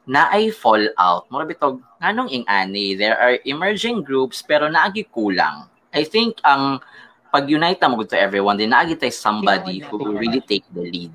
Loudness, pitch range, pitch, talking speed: -18 LUFS, 100-150 Hz, 125 Hz, 180 wpm